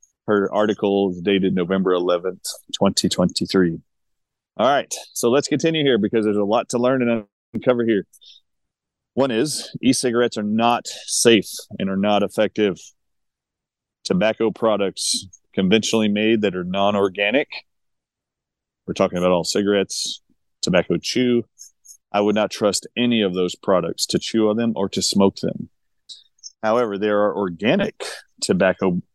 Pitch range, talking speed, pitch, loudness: 95-115 Hz, 140 wpm, 105 Hz, -20 LUFS